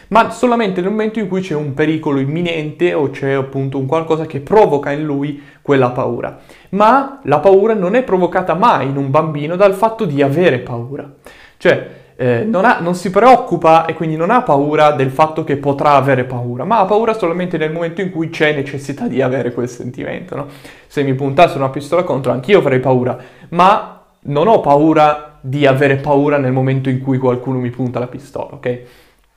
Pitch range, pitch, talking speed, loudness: 135-175 Hz, 150 Hz, 195 wpm, -14 LUFS